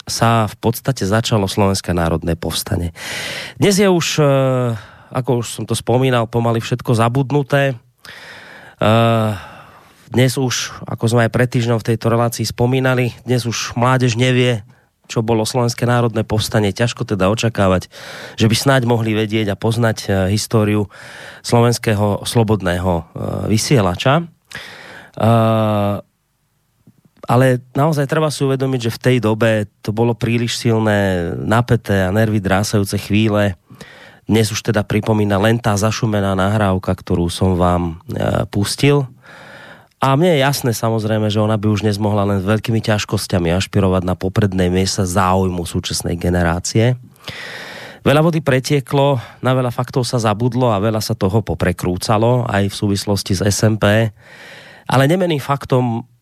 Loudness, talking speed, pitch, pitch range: -16 LUFS, 130 wpm, 115 Hz, 100-125 Hz